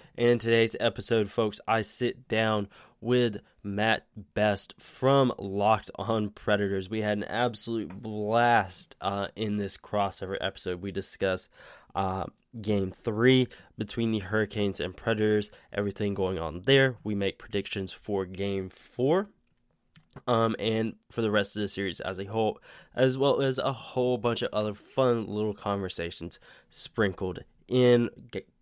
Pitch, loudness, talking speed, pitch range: 105 Hz, -28 LUFS, 145 wpm, 100-115 Hz